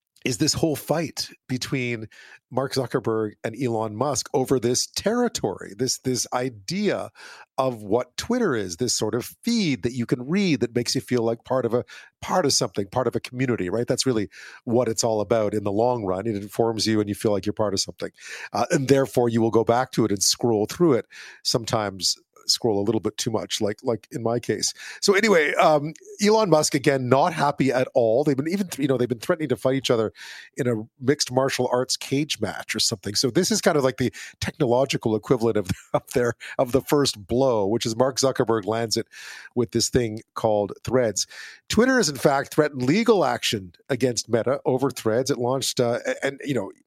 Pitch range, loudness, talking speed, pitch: 115-140 Hz, -23 LUFS, 215 wpm, 125 Hz